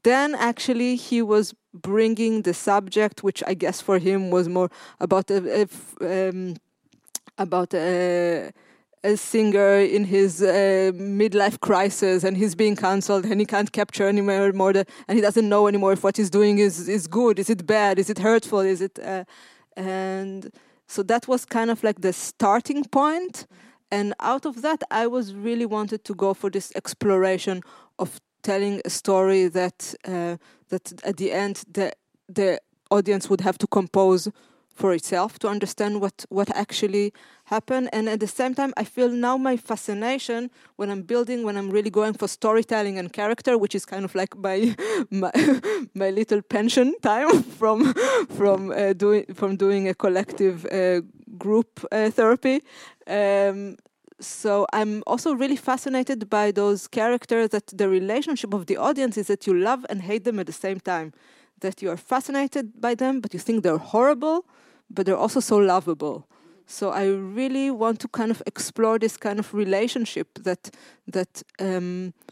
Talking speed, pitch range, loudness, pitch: 170 wpm, 195-235 Hz, -23 LUFS, 205 Hz